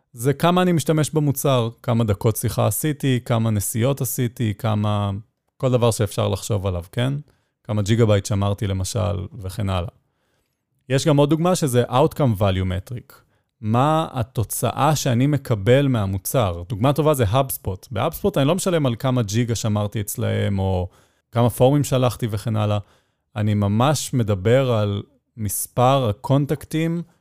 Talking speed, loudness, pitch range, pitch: 140 wpm, -21 LUFS, 105-135 Hz, 120 Hz